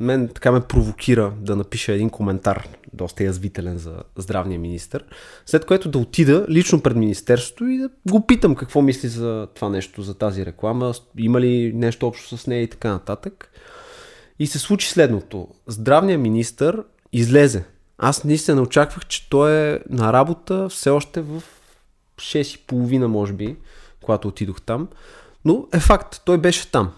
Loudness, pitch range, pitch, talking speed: -19 LUFS, 105-155 Hz, 125 Hz, 160 wpm